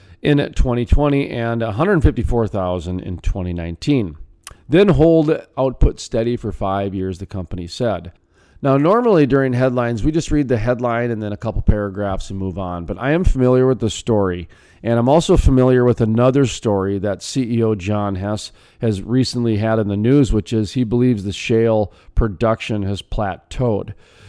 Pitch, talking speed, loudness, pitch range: 110 Hz, 165 wpm, -18 LUFS, 100-125 Hz